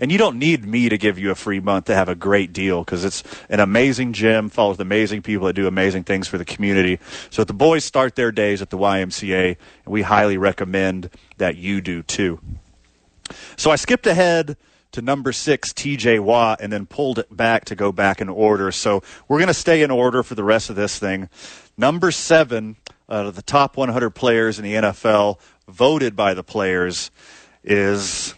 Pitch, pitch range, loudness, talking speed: 105 Hz, 95-120 Hz, -19 LUFS, 205 wpm